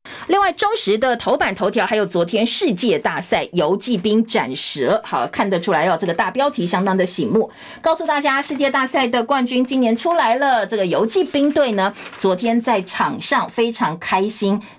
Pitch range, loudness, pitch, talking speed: 210-285 Hz, -18 LUFS, 235 Hz, 285 characters per minute